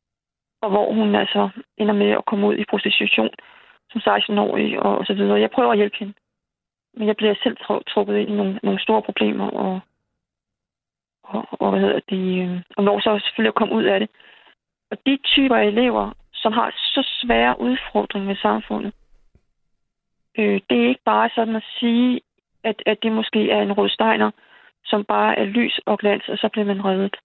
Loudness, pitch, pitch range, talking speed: -20 LUFS, 210 Hz, 195-225 Hz, 185 wpm